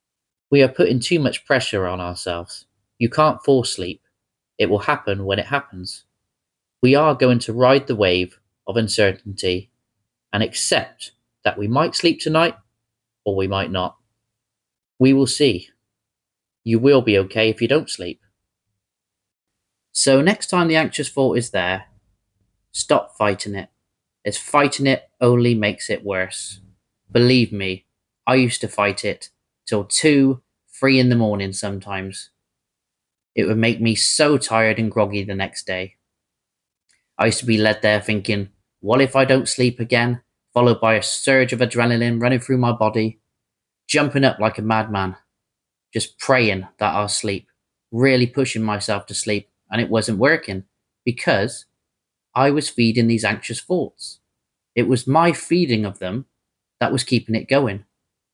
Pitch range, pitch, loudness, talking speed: 100-125 Hz, 110 Hz, -19 LUFS, 155 wpm